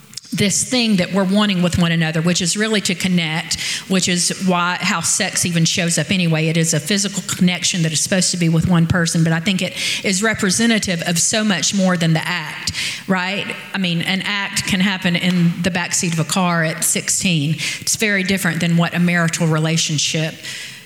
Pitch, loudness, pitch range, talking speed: 180 Hz, -17 LUFS, 165-195 Hz, 205 wpm